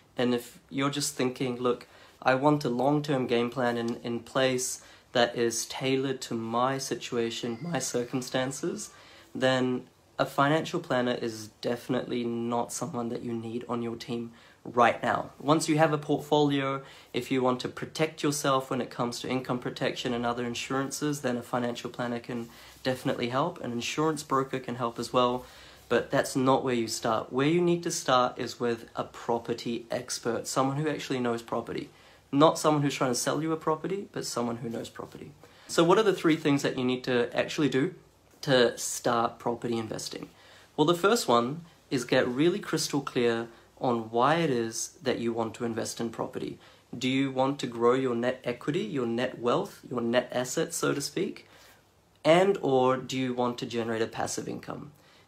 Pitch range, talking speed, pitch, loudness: 120-135 Hz, 185 wpm, 125 Hz, -29 LUFS